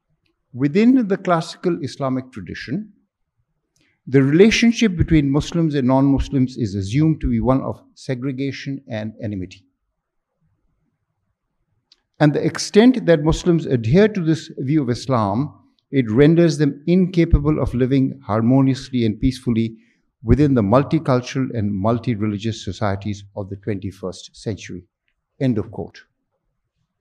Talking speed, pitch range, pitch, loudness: 120 wpm, 115-160 Hz, 135 Hz, -19 LUFS